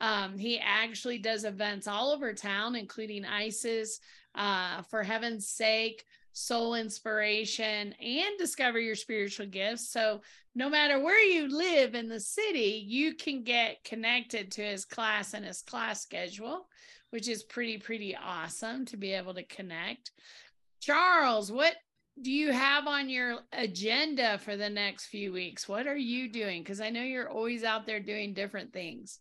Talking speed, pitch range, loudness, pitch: 160 wpm, 210-250 Hz, -31 LUFS, 225 Hz